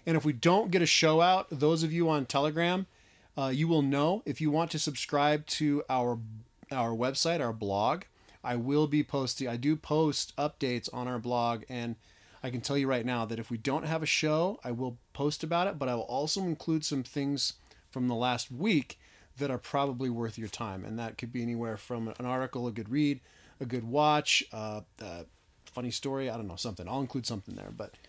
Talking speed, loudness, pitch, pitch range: 220 wpm, -31 LUFS, 130 Hz, 120-150 Hz